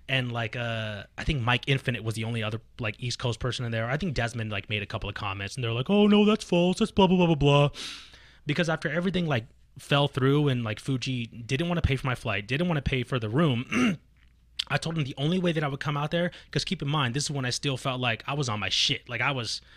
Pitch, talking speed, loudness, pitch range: 135 Hz, 280 wpm, -27 LUFS, 115-155 Hz